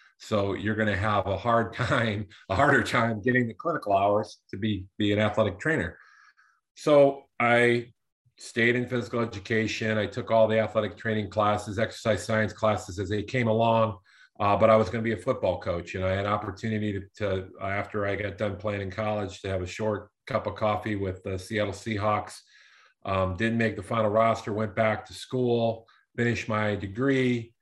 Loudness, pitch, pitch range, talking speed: -27 LUFS, 110 Hz, 100-115 Hz, 190 wpm